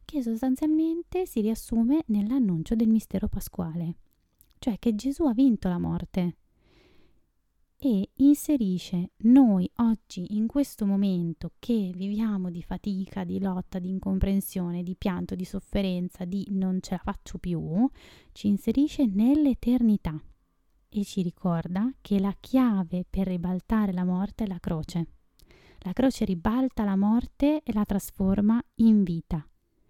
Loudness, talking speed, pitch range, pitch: -27 LUFS, 130 wpm, 185-235 Hz, 200 Hz